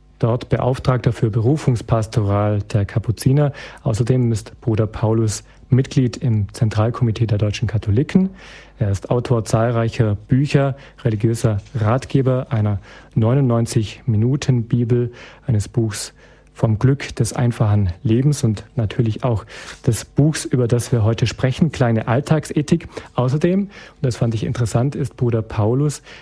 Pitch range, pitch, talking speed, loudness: 110-135 Hz, 120 Hz, 120 wpm, -19 LUFS